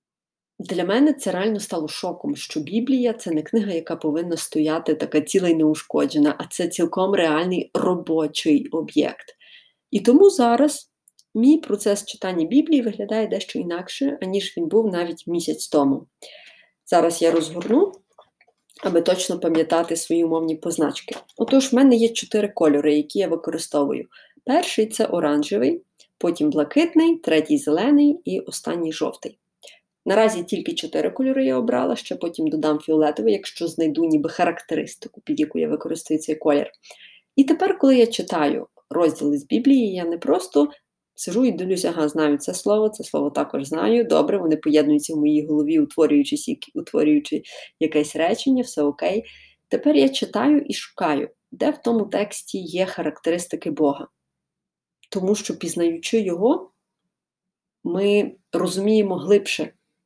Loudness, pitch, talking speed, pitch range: -21 LUFS, 185 Hz, 140 wpm, 160-240 Hz